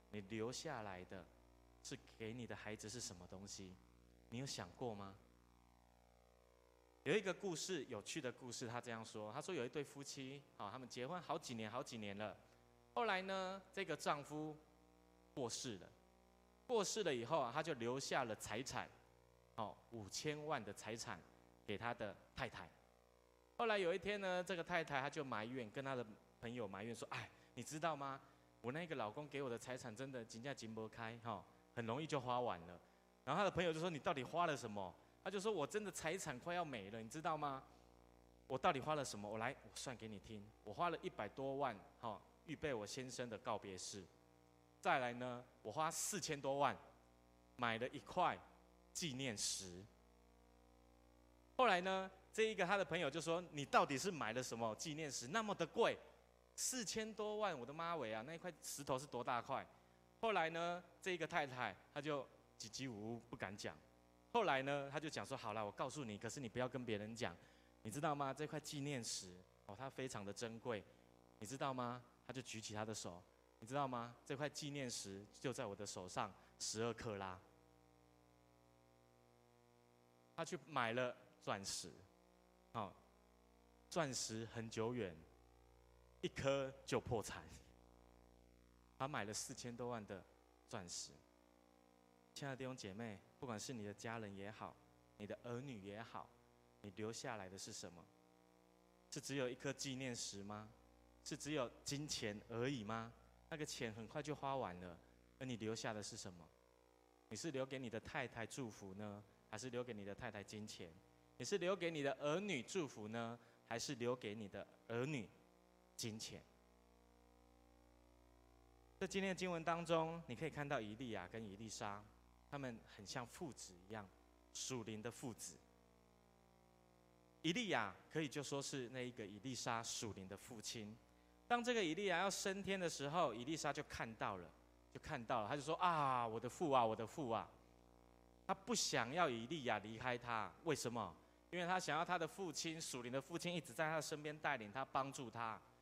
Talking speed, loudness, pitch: 250 characters per minute, -46 LUFS, 110 Hz